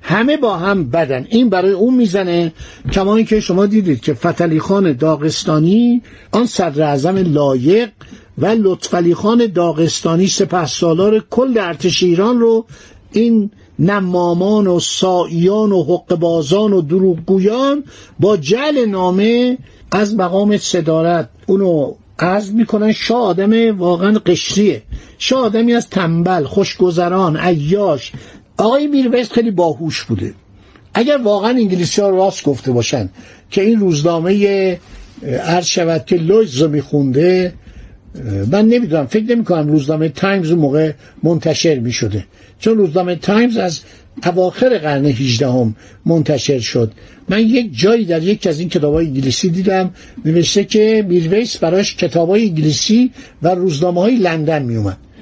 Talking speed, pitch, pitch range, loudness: 130 wpm, 180 Hz, 160-210 Hz, -14 LUFS